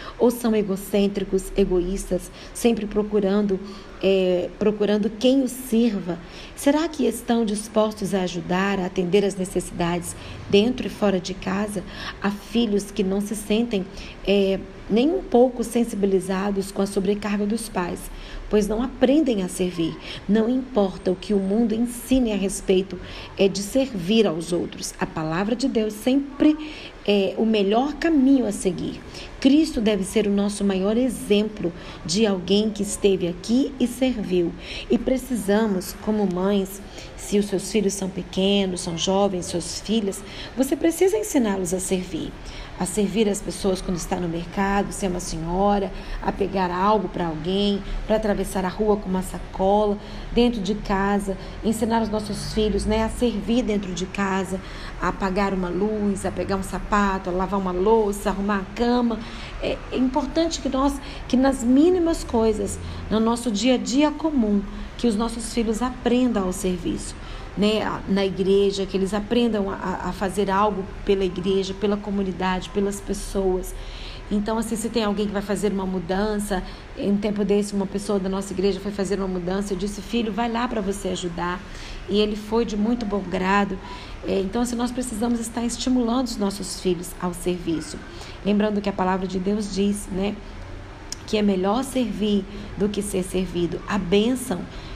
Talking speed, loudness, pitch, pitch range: 165 wpm, -23 LUFS, 200 Hz, 190-225 Hz